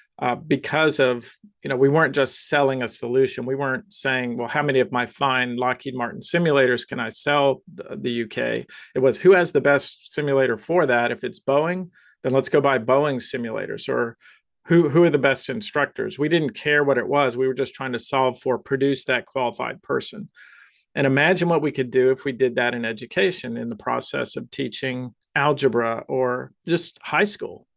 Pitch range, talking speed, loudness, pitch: 130-155 Hz, 200 wpm, -22 LUFS, 135 Hz